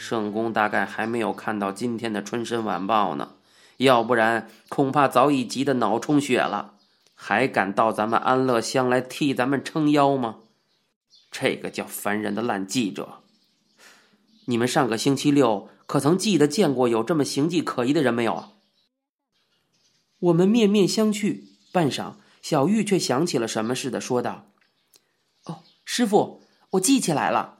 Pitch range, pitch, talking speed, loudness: 115-170 Hz, 125 Hz, 235 characters per minute, -23 LUFS